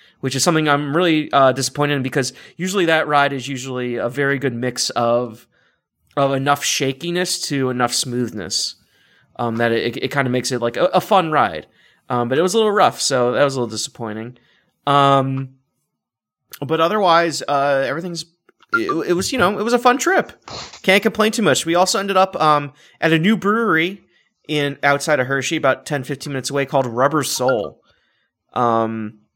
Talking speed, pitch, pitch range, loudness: 190 wpm, 140 Hz, 130-175 Hz, -18 LUFS